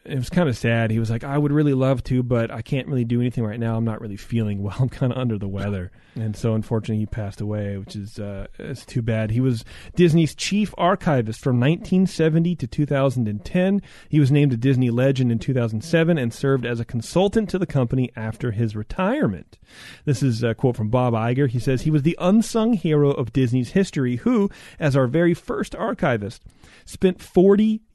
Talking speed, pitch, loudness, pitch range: 210 wpm, 130 Hz, -21 LUFS, 115-155 Hz